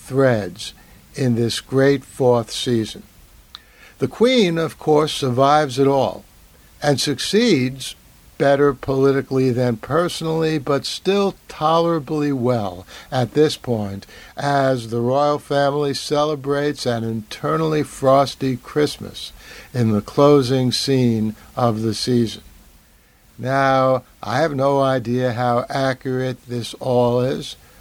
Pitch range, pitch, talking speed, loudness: 120-145 Hz, 135 Hz, 110 wpm, -19 LUFS